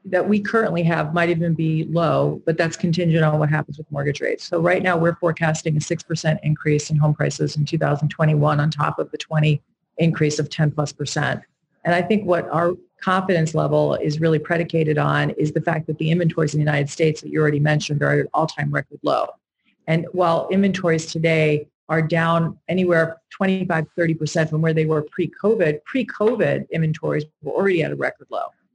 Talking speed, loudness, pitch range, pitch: 195 wpm, -21 LUFS, 150-170 Hz, 160 Hz